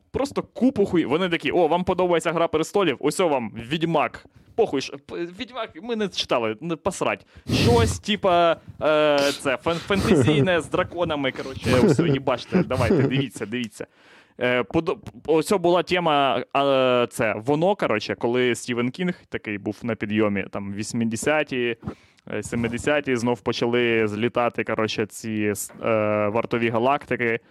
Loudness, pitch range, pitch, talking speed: -23 LUFS, 115-165 Hz, 135 Hz, 135 wpm